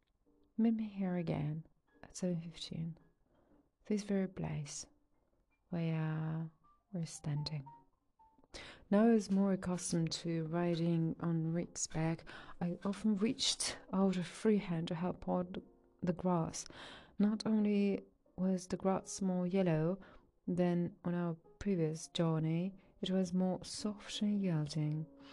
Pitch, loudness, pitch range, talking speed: 175 Hz, -37 LUFS, 160-195 Hz, 125 wpm